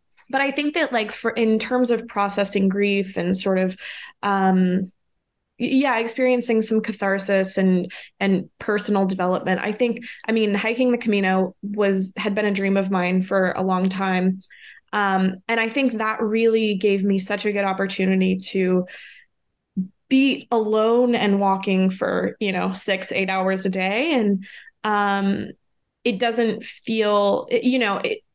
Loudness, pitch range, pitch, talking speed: -21 LUFS, 190-225 Hz, 200 Hz, 155 wpm